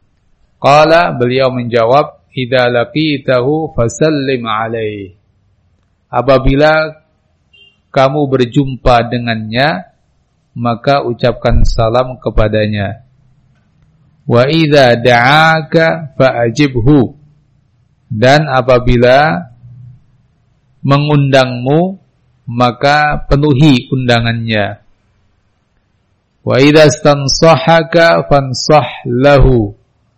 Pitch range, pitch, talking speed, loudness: 115-145 Hz, 130 Hz, 60 wpm, -10 LUFS